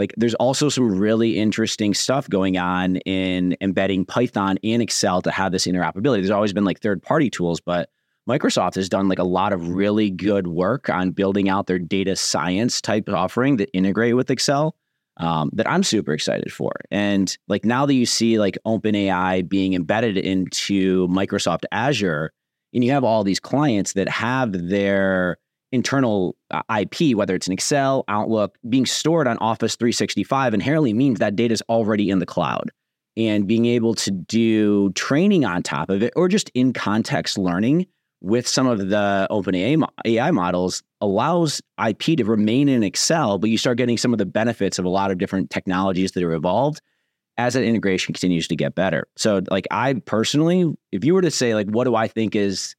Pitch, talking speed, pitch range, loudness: 100 Hz, 190 wpm, 95-115 Hz, -20 LUFS